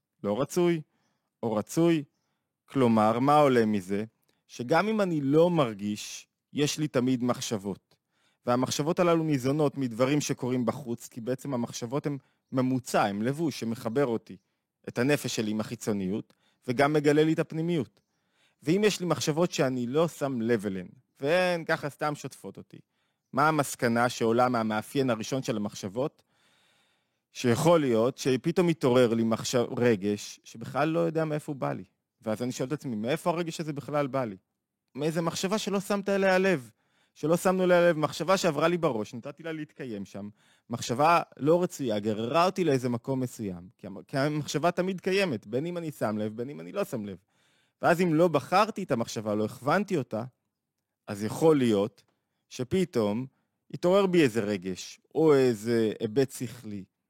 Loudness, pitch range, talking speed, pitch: -28 LUFS, 115-165 Hz, 160 wpm, 140 Hz